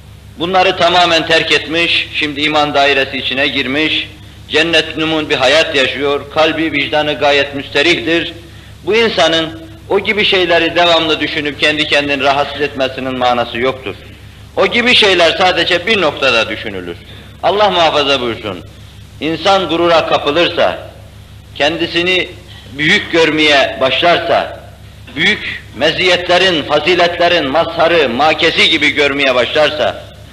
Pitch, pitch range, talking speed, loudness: 150 Hz, 130-165 Hz, 110 wpm, -11 LUFS